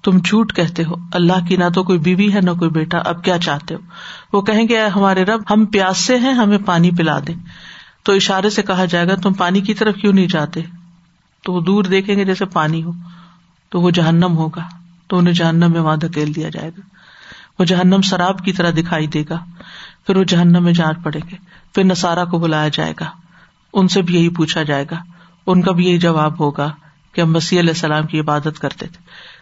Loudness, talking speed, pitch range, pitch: -15 LUFS, 220 wpm, 165-190 Hz, 175 Hz